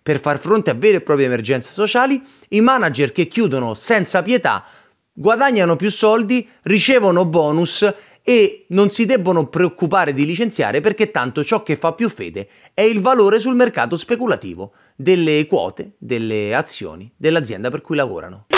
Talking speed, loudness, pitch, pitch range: 155 wpm, -17 LUFS, 185 Hz, 150-220 Hz